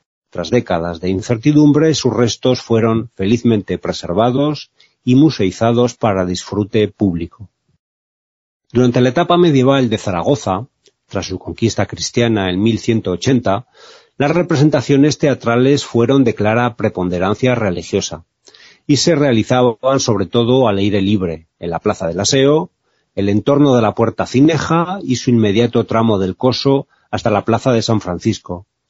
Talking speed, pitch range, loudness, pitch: 135 wpm, 100-130 Hz, -15 LUFS, 115 Hz